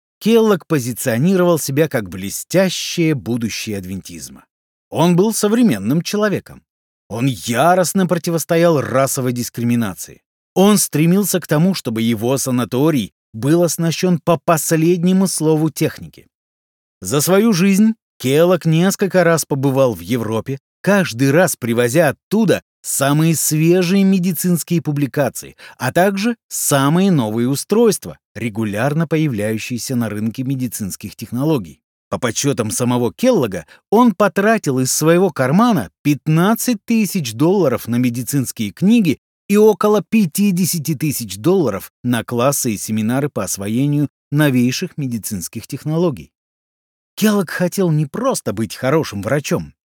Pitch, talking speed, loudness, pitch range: 150 Hz, 110 wpm, -16 LUFS, 120-180 Hz